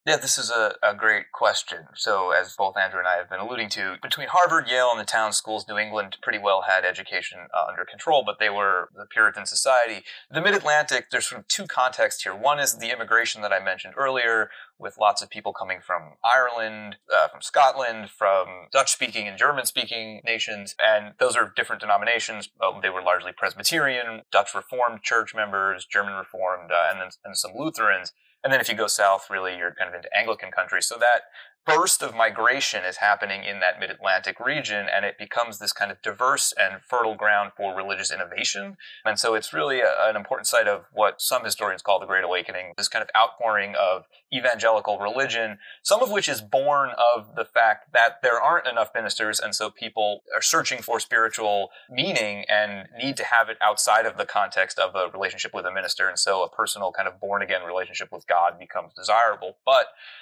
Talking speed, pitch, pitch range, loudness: 200 wpm, 110 Hz, 100-120 Hz, -23 LUFS